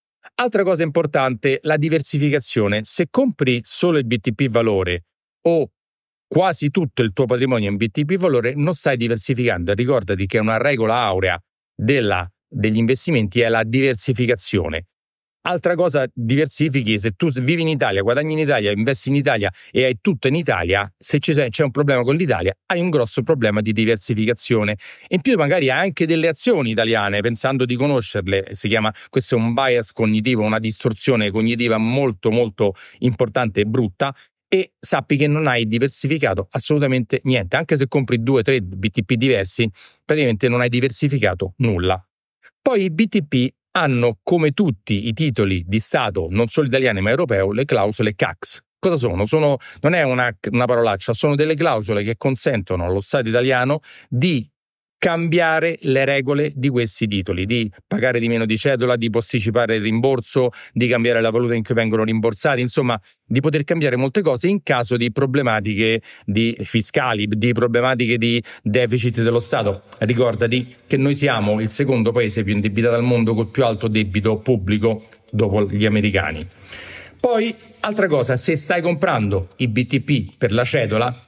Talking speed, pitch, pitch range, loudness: 160 wpm, 120 Hz, 110-145 Hz, -19 LUFS